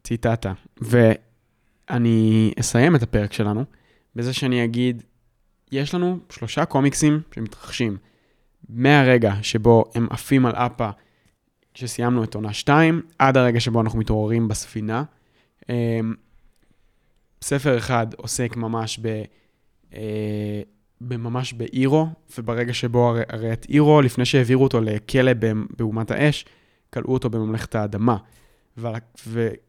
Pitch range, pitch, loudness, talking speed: 110-125 Hz, 115 Hz, -21 LUFS, 110 wpm